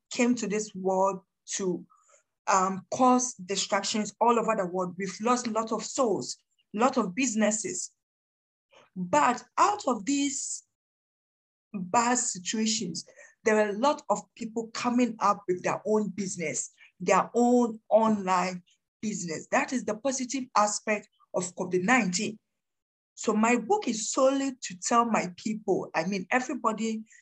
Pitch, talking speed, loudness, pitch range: 215 Hz, 140 wpm, -28 LUFS, 195-245 Hz